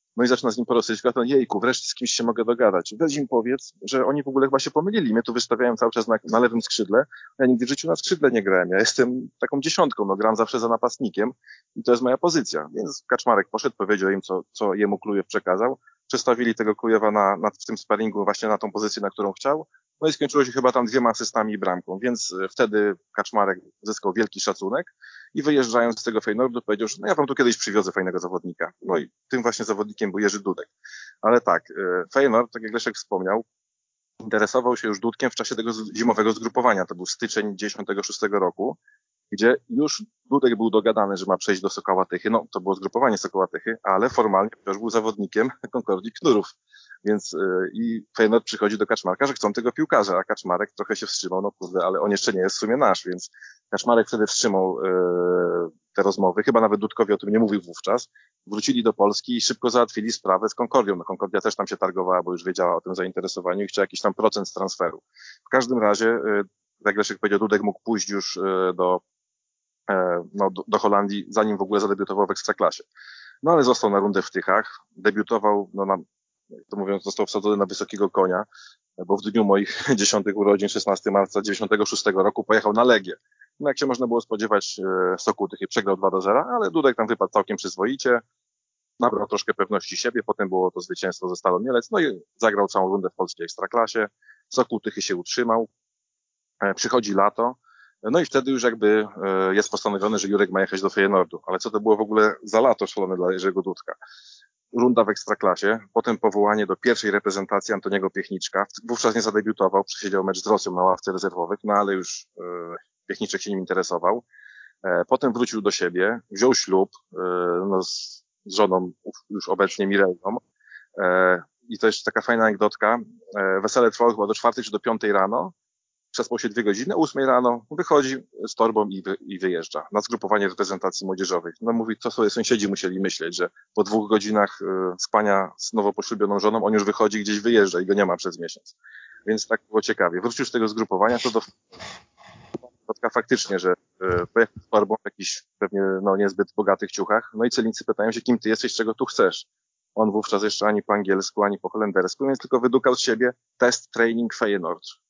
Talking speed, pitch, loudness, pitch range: 195 wpm, 110 Hz, -23 LUFS, 100-120 Hz